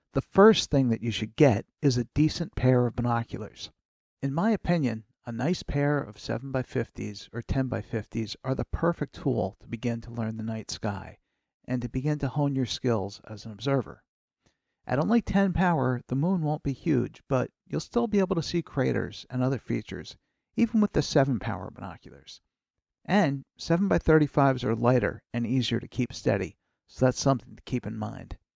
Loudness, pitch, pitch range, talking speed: -27 LUFS, 130 Hz, 115-150 Hz, 180 wpm